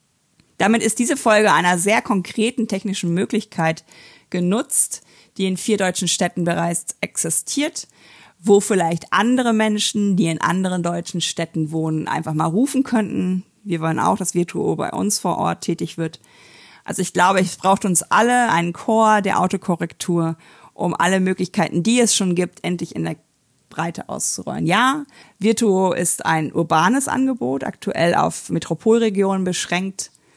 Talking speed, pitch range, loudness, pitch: 150 wpm, 170-215 Hz, -19 LUFS, 185 Hz